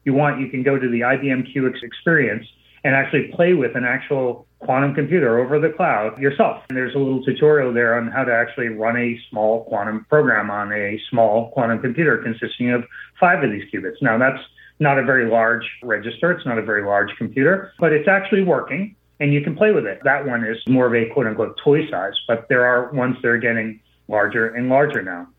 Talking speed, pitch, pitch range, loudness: 215 wpm, 125 Hz, 115-140 Hz, -19 LUFS